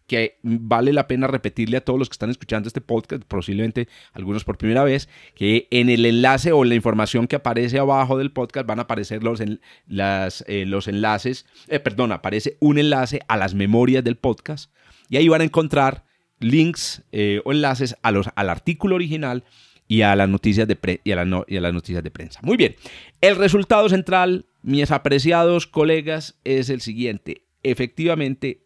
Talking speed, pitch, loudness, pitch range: 190 wpm, 125 Hz, -20 LUFS, 110-140 Hz